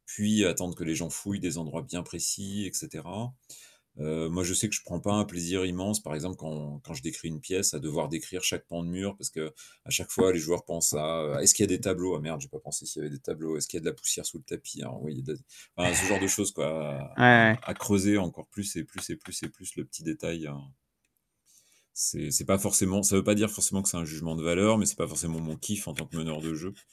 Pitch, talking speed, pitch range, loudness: 90 Hz, 280 wpm, 80-100 Hz, -29 LUFS